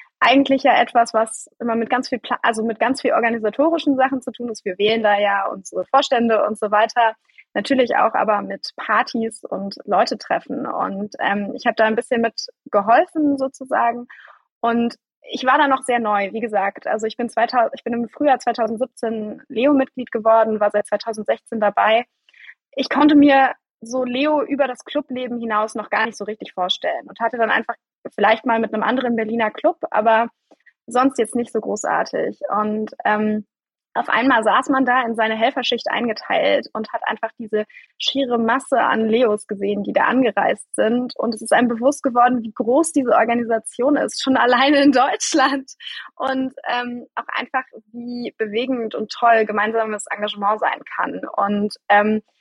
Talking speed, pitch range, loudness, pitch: 175 wpm, 220-265 Hz, -19 LUFS, 235 Hz